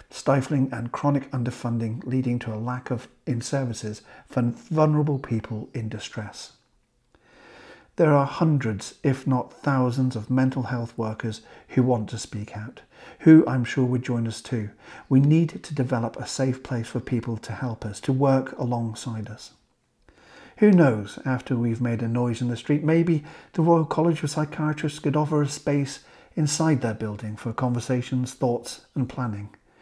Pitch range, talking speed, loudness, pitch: 115-145 Hz, 165 wpm, -25 LUFS, 125 Hz